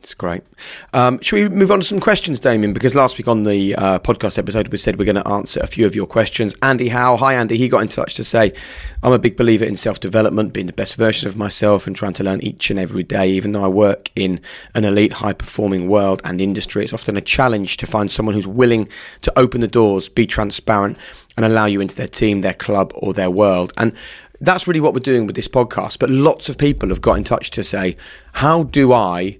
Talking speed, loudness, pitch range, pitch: 245 wpm, -16 LUFS, 100-125 Hz, 110 Hz